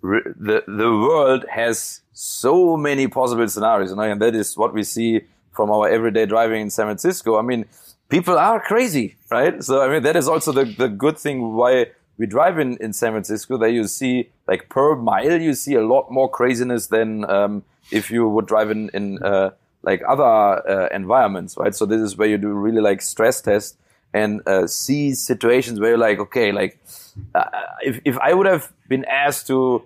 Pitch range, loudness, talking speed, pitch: 110-130 Hz, -19 LUFS, 200 wpm, 115 Hz